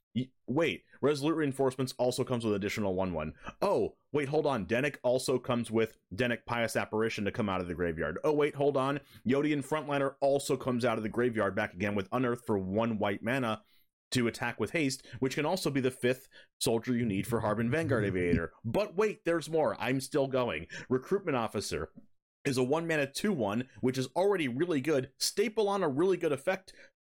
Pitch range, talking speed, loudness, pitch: 110-140 Hz, 195 wpm, -32 LUFS, 125 Hz